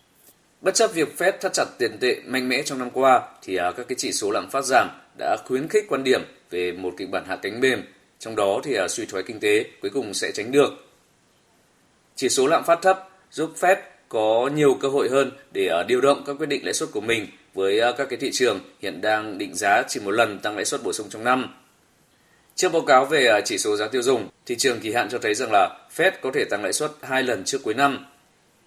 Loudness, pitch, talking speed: -22 LUFS, 150 Hz, 240 wpm